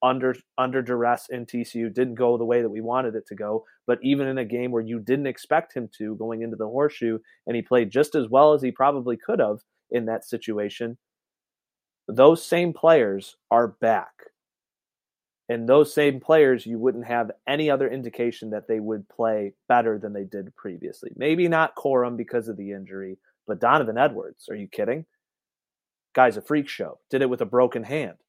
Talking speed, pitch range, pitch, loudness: 195 wpm, 115-135 Hz, 120 Hz, -23 LUFS